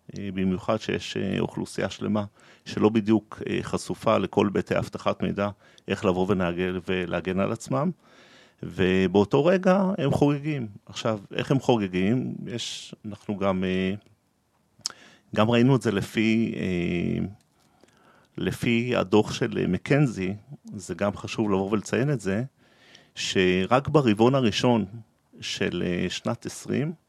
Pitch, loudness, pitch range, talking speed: 105 Hz, -25 LUFS, 95-125 Hz, 105 wpm